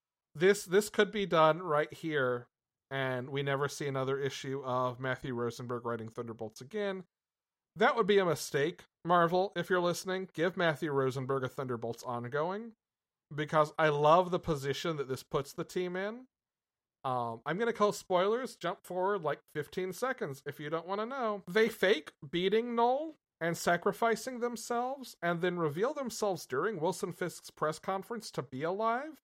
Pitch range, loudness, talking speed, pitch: 140-205 Hz, -33 LUFS, 165 wpm, 170 Hz